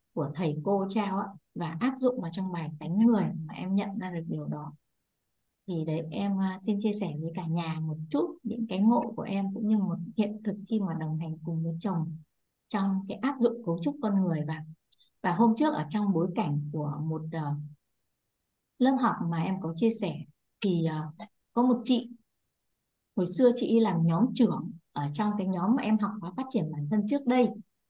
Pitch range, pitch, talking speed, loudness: 160-220 Hz, 195 Hz, 205 wpm, -30 LUFS